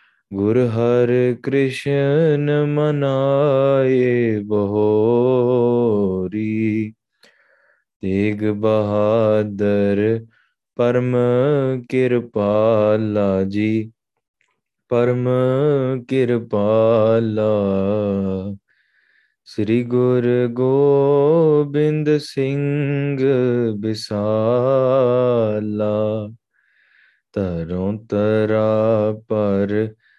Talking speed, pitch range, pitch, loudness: 40 wpm, 105-130 Hz, 115 Hz, -18 LUFS